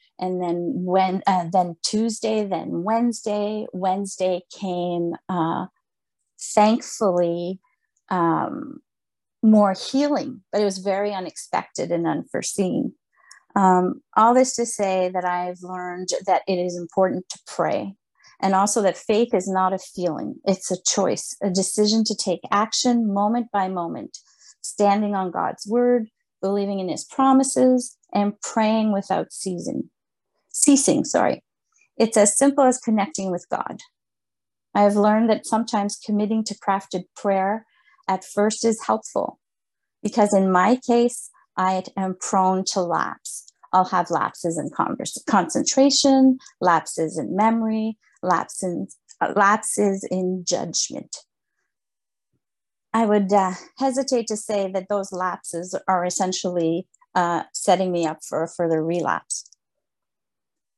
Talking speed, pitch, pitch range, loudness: 130 wpm, 200 Hz, 185-225 Hz, -22 LUFS